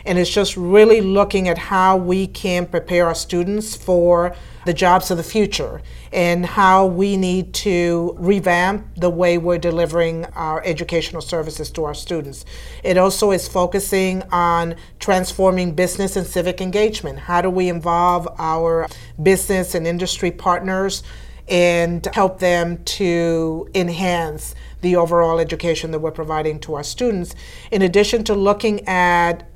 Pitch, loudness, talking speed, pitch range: 175 Hz, -18 LUFS, 145 wpm, 170-190 Hz